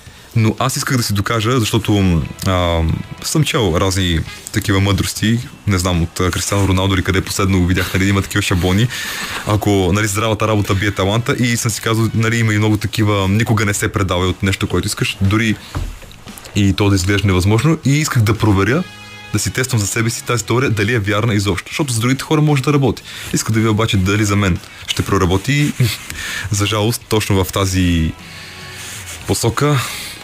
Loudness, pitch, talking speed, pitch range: -16 LUFS, 105 Hz, 185 wpm, 95-115 Hz